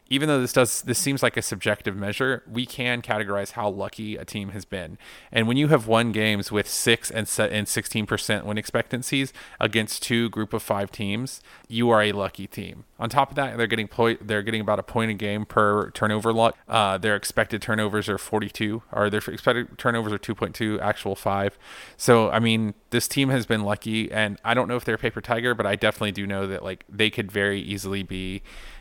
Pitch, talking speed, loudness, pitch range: 110 Hz, 225 wpm, -24 LUFS, 105-115 Hz